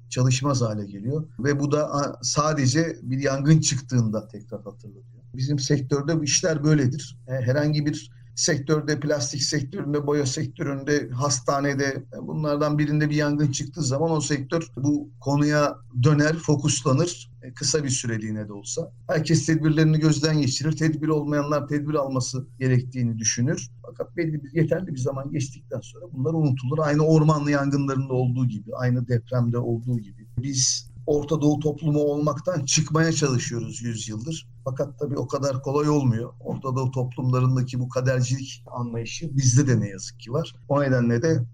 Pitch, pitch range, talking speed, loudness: 140 Hz, 125-150 Hz, 145 wpm, -24 LUFS